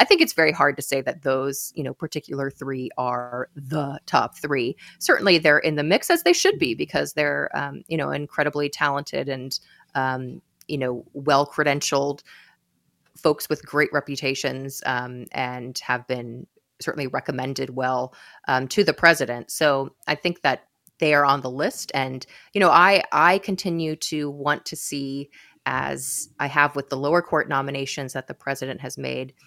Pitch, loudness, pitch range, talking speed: 140 Hz, -23 LUFS, 130-150 Hz, 175 wpm